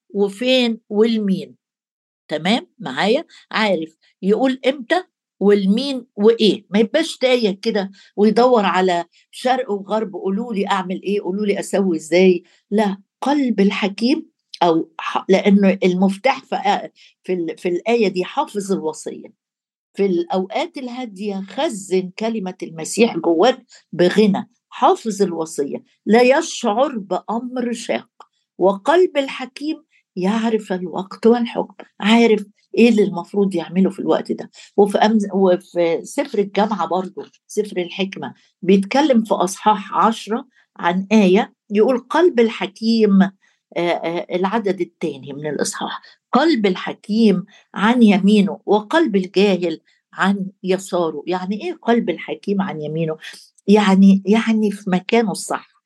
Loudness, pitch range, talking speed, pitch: -18 LUFS, 185-230 Hz, 115 wpm, 205 Hz